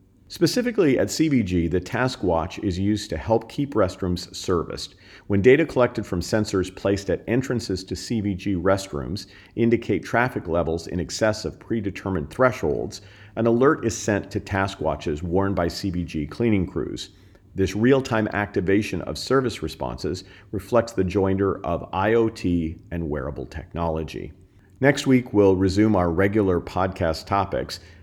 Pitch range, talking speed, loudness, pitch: 90-110 Hz, 145 wpm, -23 LUFS, 100 Hz